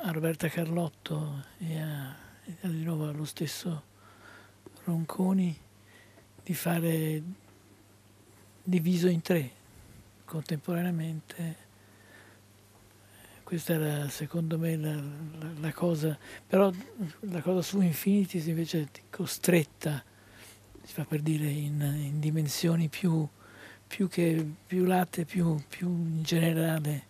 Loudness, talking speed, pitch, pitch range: -31 LUFS, 110 wpm, 155 Hz, 115-170 Hz